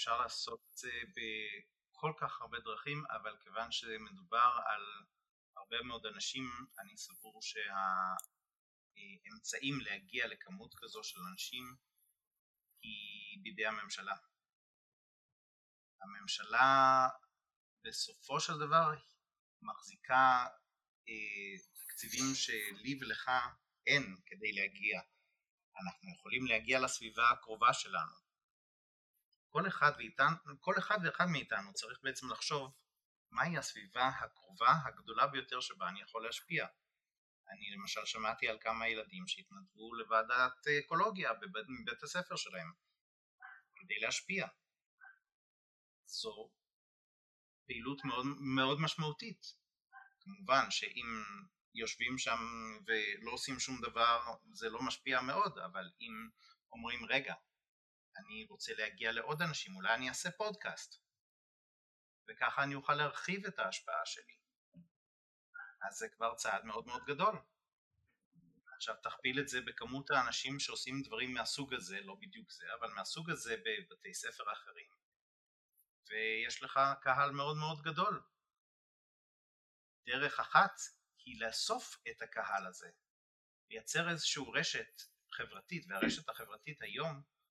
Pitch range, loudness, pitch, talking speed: 120-200 Hz, -38 LUFS, 140 Hz, 110 wpm